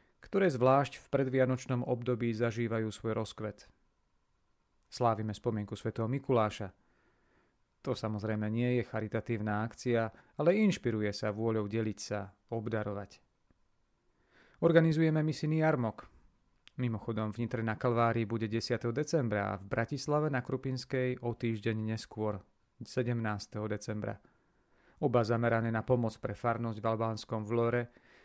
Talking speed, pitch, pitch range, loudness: 115 wpm, 115 Hz, 110-125 Hz, -33 LUFS